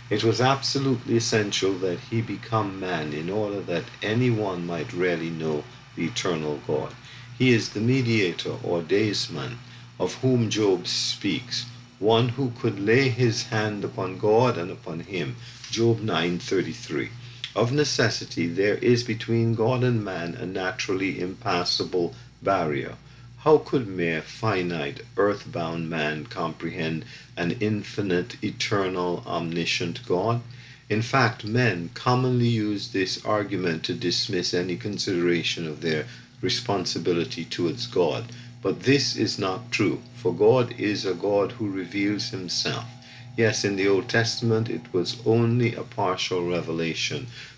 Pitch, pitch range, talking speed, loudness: 110 Hz, 95-120 Hz, 135 wpm, -25 LUFS